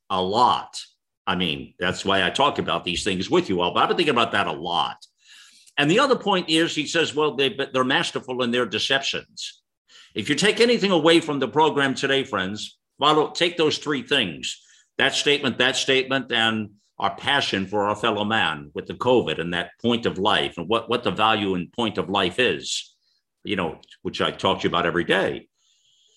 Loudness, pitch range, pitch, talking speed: -22 LUFS, 110-150 Hz, 130 Hz, 205 wpm